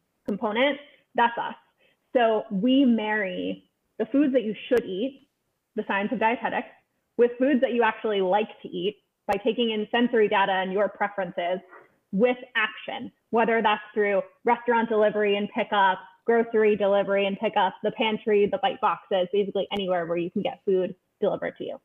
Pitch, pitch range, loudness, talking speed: 215 Hz, 195-235 Hz, -25 LUFS, 165 wpm